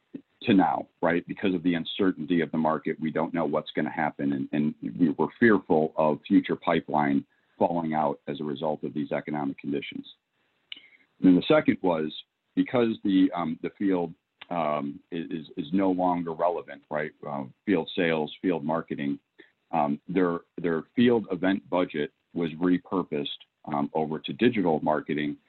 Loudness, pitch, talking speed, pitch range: -27 LUFS, 80 Hz, 160 wpm, 75-90 Hz